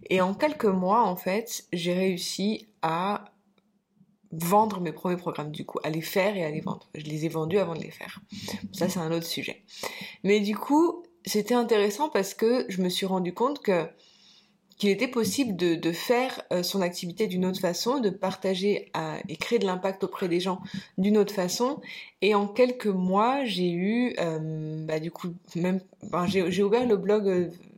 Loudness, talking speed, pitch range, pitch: -27 LUFS, 195 wpm, 175-210 Hz, 190 Hz